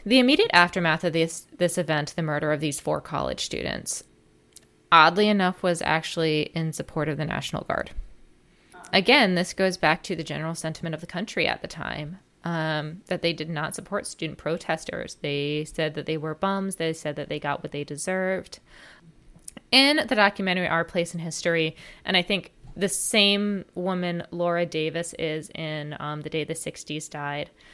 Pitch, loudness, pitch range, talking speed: 165 Hz, -25 LUFS, 155-185 Hz, 180 wpm